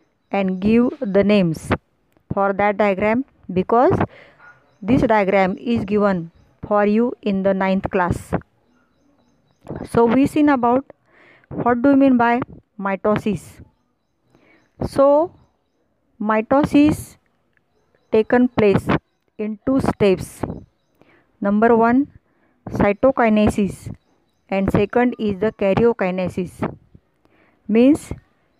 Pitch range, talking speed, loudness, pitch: 195-245 Hz, 90 wpm, -18 LUFS, 215 Hz